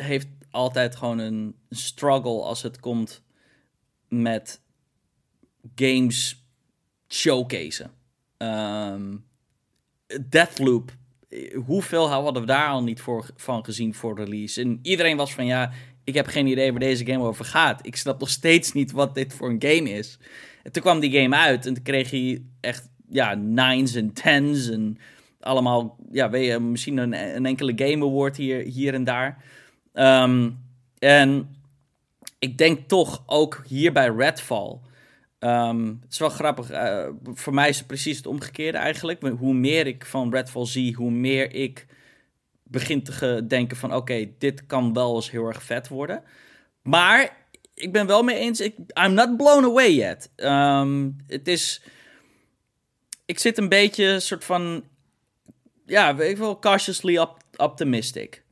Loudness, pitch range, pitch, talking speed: -22 LUFS, 120-145 Hz, 130 Hz, 155 wpm